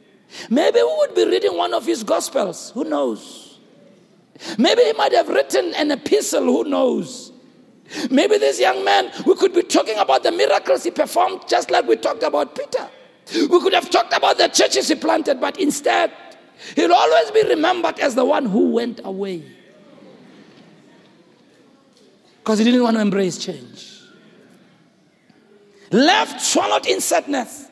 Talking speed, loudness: 155 wpm, -18 LUFS